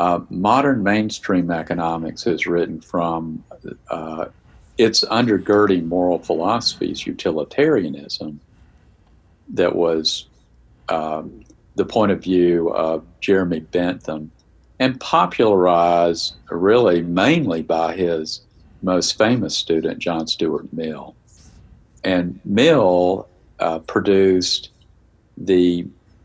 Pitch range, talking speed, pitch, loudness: 80-95 Hz, 90 wpm, 85 Hz, -19 LUFS